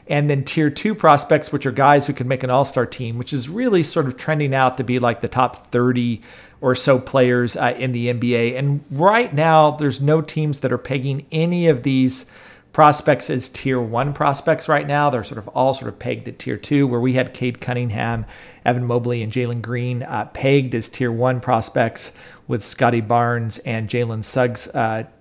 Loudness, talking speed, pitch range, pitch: -19 LUFS, 205 wpm, 120-145 Hz, 130 Hz